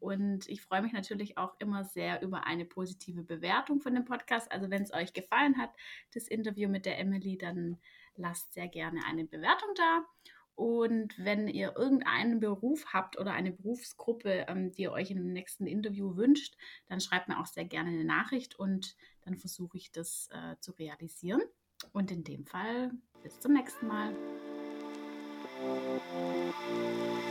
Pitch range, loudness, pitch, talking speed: 170-230 Hz, -35 LUFS, 190 Hz, 160 wpm